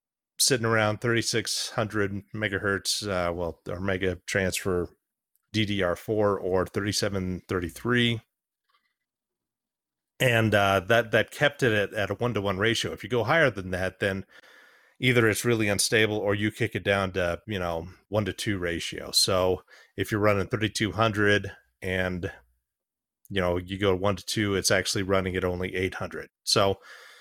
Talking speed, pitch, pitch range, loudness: 150 wpm, 100 Hz, 95-110 Hz, -26 LUFS